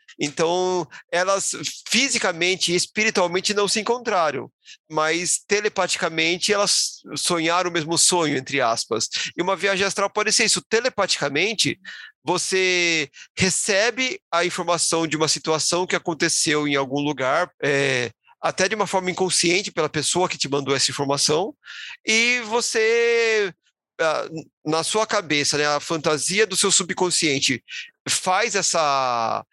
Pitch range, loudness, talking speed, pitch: 155-205 Hz, -21 LUFS, 130 wpm, 180 Hz